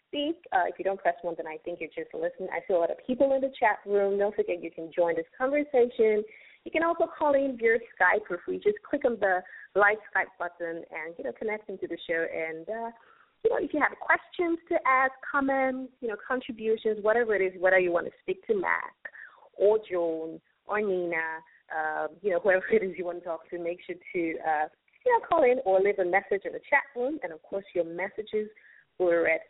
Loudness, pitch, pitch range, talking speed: -28 LUFS, 205 Hz, 175-270 Hz, 235 wpm